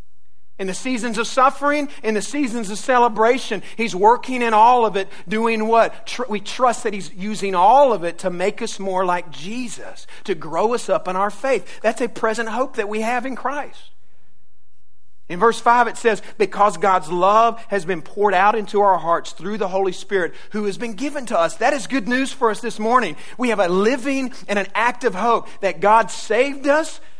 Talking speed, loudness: 205 wpm, -19 LUFS